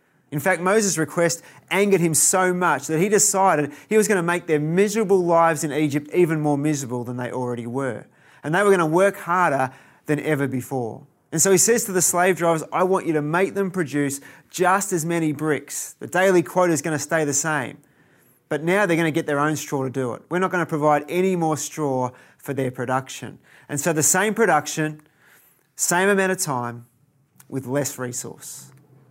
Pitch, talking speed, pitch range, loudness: 155 Hz, 210 wpm, 140-180 Hz, -21 LUFS